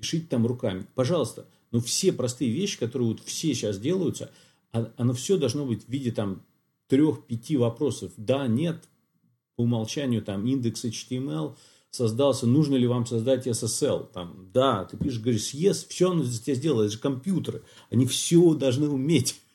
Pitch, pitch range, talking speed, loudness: 125 Hz, 115-145 Hz, 165 wpm, -26 LUFS